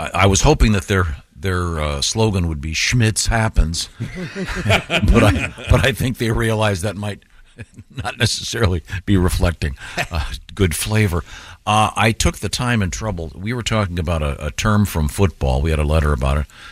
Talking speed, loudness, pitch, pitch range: 180 wpm, -19 LUFS, 95 Hz, 80-110 Hz